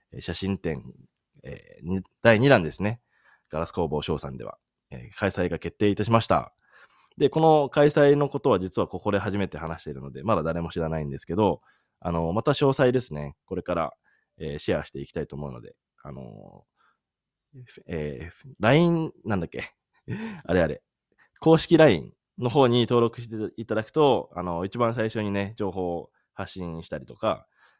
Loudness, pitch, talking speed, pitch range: -25 LUFS, 100 Hz, 330 characters per minute, 85-125 Hz